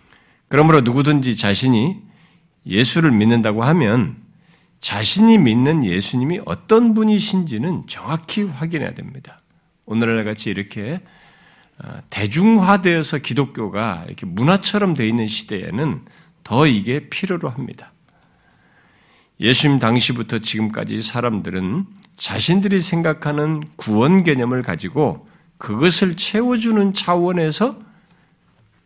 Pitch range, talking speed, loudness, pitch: 120-185 Hz, 270 characters per minute, -18 LUFS, 155 Hz